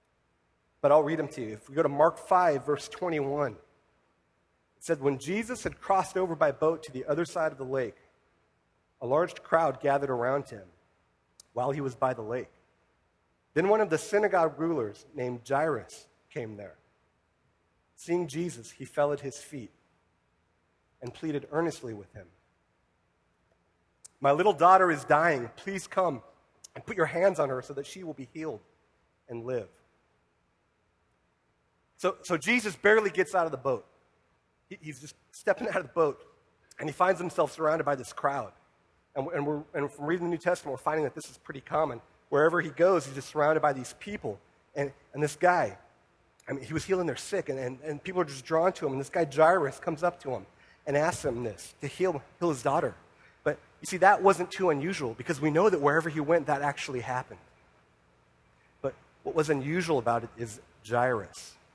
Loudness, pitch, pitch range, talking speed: -29 LUFS, 145 Hz, 120-170 Hz, 190 wpm